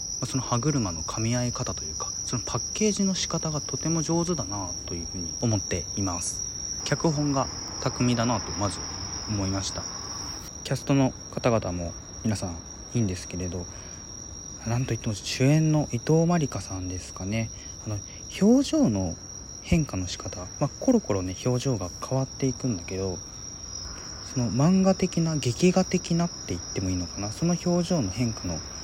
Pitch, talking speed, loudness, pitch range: 105 Hz, 335 characters per minute, -27 LUFS, 90-135 Hz